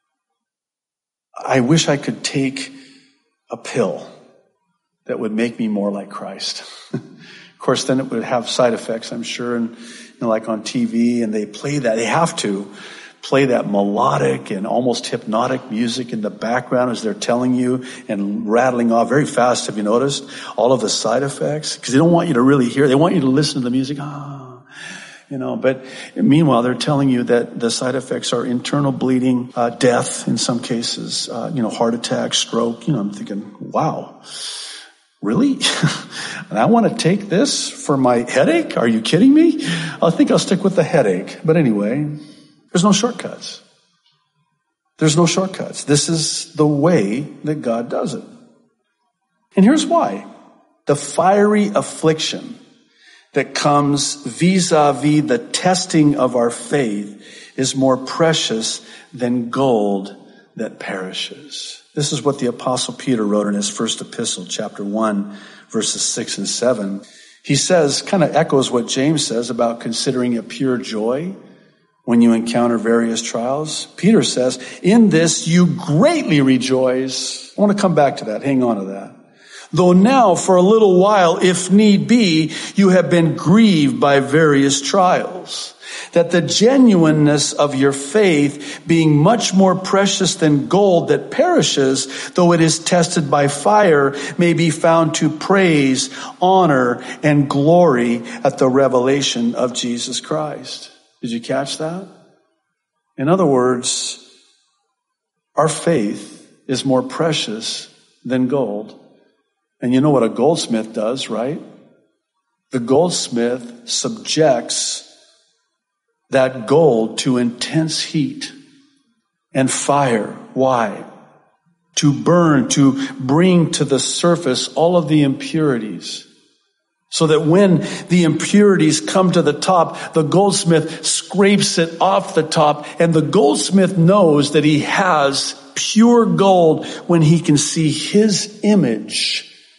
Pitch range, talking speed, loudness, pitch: 125-180 Hz, 150 wpm, -16 LUFS, 150 Hz